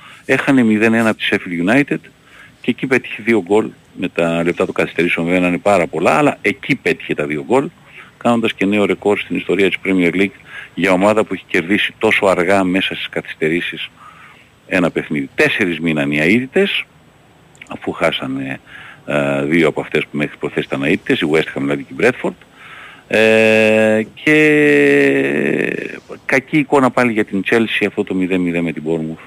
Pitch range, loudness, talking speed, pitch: 85-115 Hz, -15 LUFS, 170 wpm, 100 Hz